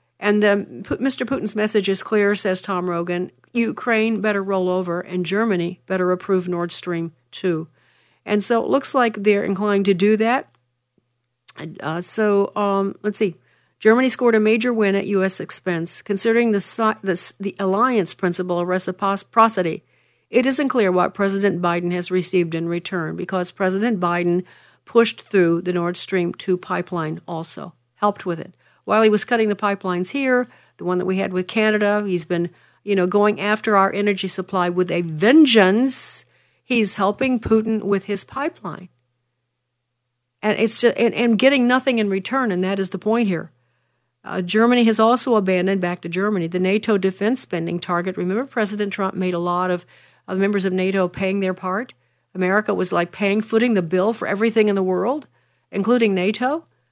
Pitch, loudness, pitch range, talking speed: 195 Hz, -20 LUFS, 180-215 Hz, 175 wpm